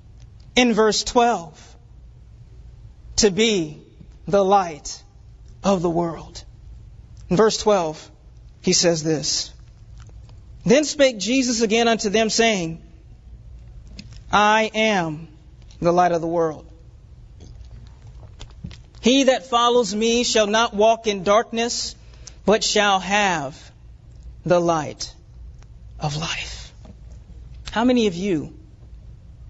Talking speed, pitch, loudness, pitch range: 100 wpm, 200 Hz, -20 LUFS, 160-225 Hz